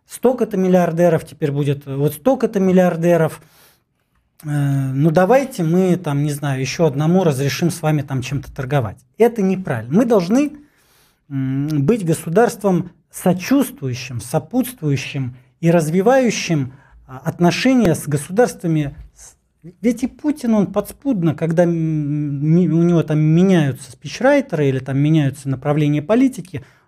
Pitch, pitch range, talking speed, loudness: 160 Hz, 145-190 Hz, 120 wpm, -17 LUFS